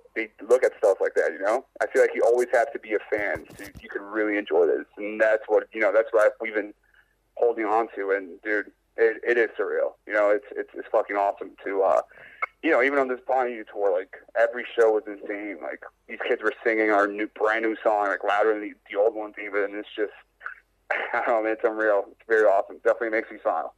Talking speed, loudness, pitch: 240 wpm, -25 LUFS, 120 Hz